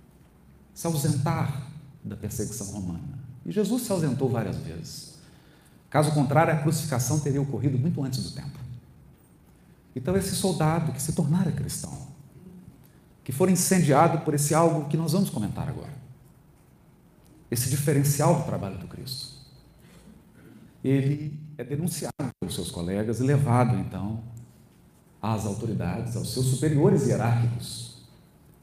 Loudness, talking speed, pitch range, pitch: -26 LUFS, 125 wpm, 125-160 Hz, 145 Hz